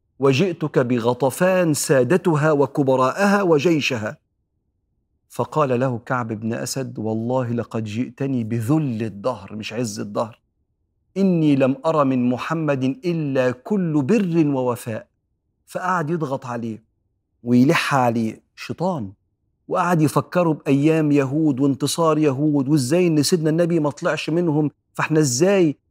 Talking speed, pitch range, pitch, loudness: 110 wpm, 120-155 Hz, 140 Hz, -20 LUFS